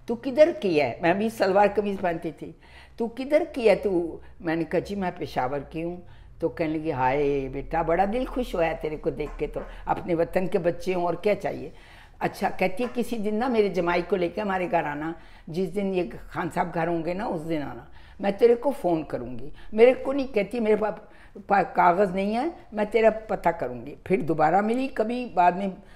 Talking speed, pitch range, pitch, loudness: 215 wpm, 165-220 Hz, 185 Hz, -25 LUFS